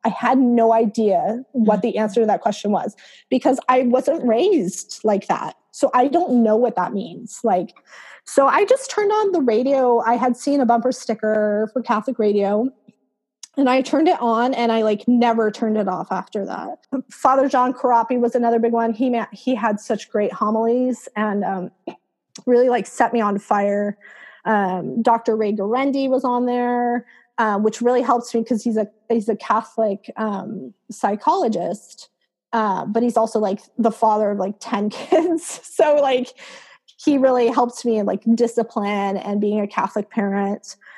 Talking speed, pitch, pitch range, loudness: 180 wpm, 230 Hz, 215-250 Hz, -19 LUFS